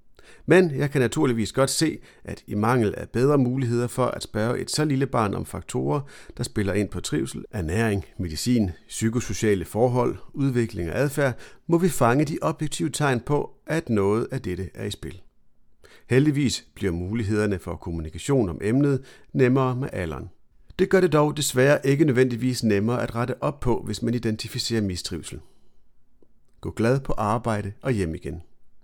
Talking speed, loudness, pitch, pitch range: 165 wpm, -24 LUFS, 120 Hz, 105-135 Hz